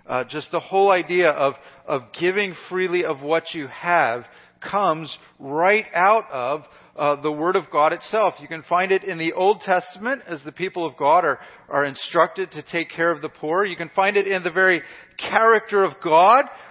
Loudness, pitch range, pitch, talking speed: -21 LUFS, 150-190 Hz, 170 Hz, 200 wpm